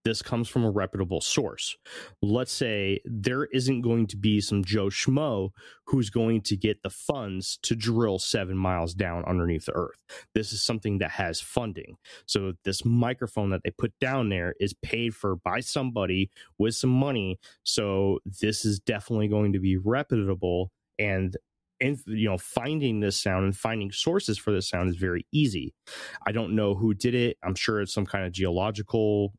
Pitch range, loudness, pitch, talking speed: 95-115 Hz, -28 LUFS, 105 Hz, 180 wpm